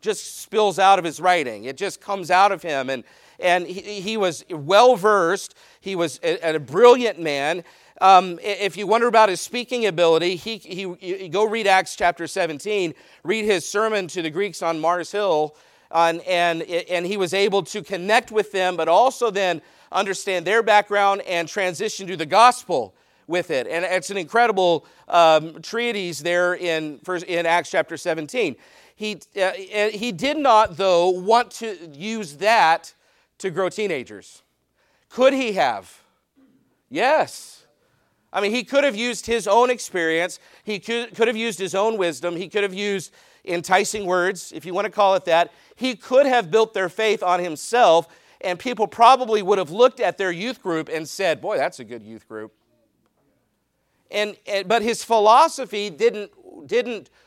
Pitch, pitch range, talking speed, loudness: 195 Hz, 175-220 Hz, 175 wpm, -20 LUFS